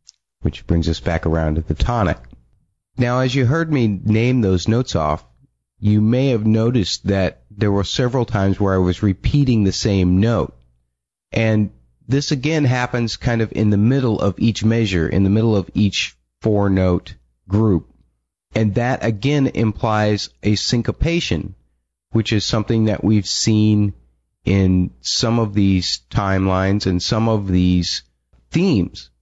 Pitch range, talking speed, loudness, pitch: 90-115 Hz, 155 wpm, -18 LUFS, 105 Hz